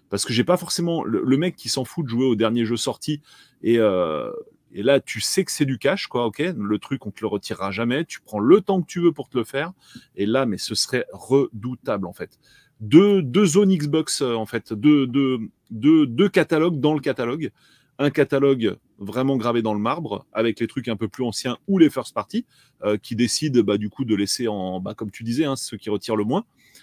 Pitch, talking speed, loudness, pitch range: 130 Hz, 235 wpm, -22 LUFS, 110-155 Hz